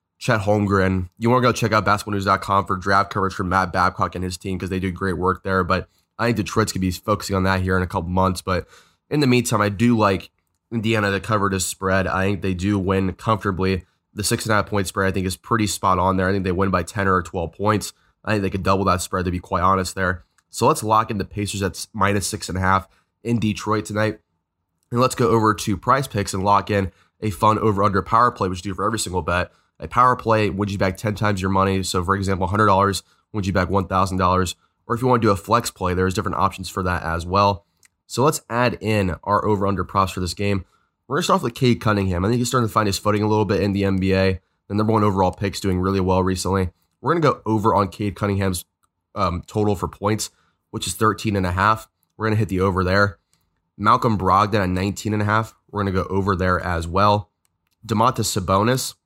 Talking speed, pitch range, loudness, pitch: 245 wpm, 95-105 Hz, -21 LUFS, 100 Hz